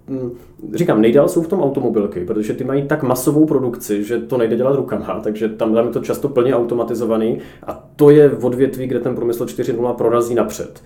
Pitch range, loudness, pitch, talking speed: 115-130 Hz, -17 LUFS, 120 Hz, 195 wpm